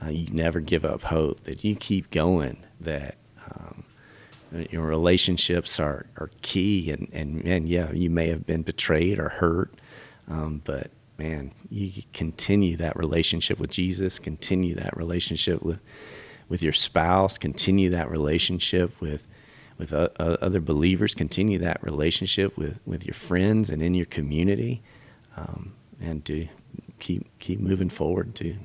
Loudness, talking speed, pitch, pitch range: -25 LUFS, 150 wpm, 85 Hz, 80-95 Hz